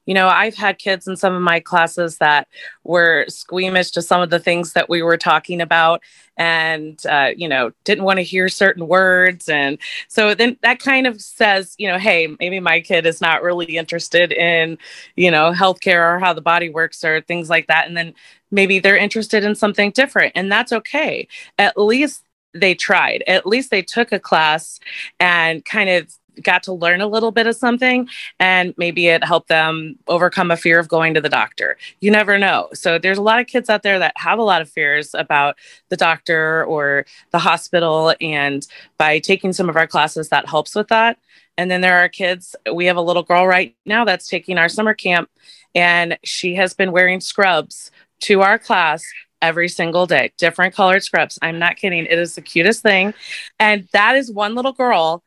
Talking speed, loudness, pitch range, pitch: 205 wpm, -15 LUFS, 165-200 Hz, 180 Hz